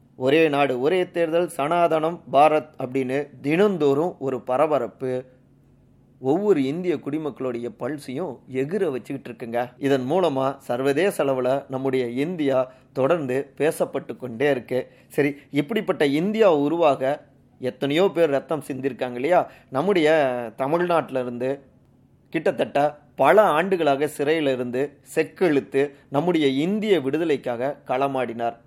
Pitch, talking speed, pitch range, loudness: 140 Hz, 100 wpm, 130-155 Hz, -23 LUFS